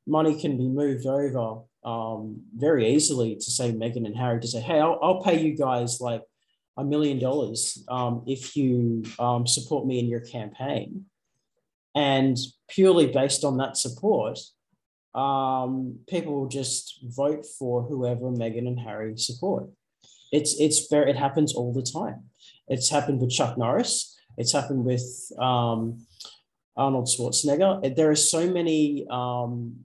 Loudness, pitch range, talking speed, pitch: -25 LUFS, 120-145 Hz, 150 wpm, 130 Hz